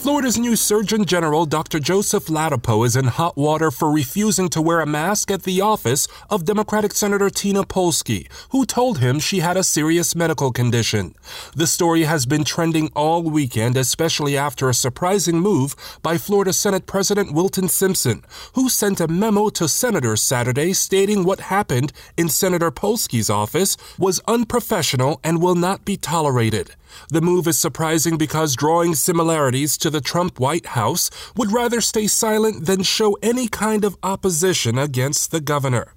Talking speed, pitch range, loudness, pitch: 165 wpm, 150-200 Hz, -18 LUFS, 170 Hz